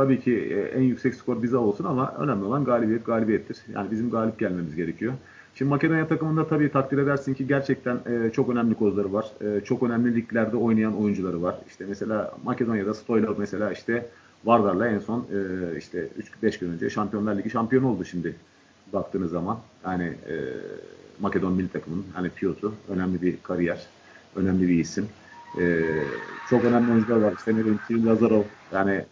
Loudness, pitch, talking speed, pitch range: -25 LUFS, 110 Hz, 155 wpm, 95-120 Hz